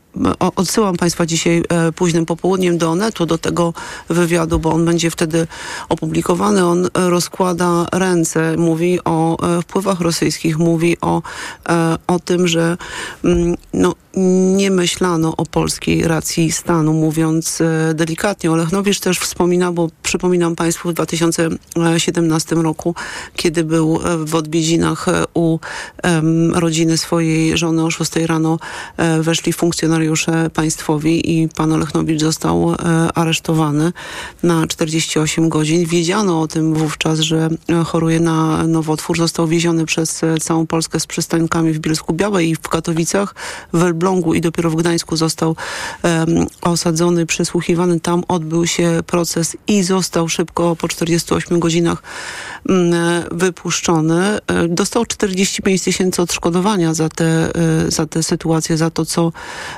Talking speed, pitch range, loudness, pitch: 125 wpm, 160-175 Hz, -16 LUFS, 165 Hz